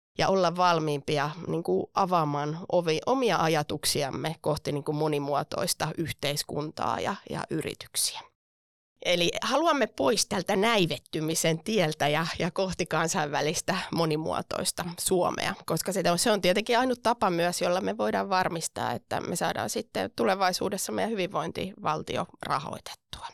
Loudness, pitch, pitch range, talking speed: -28 LUFS, 170 Hz, 155-185 Hz, 130 wpm